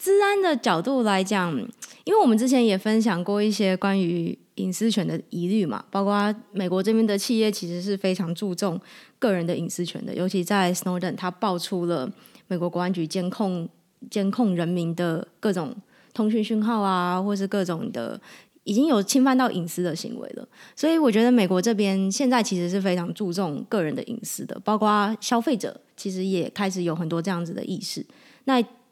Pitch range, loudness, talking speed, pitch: 180-235 Hz, -24 LUFS, 300 characters per minute, 200 Hz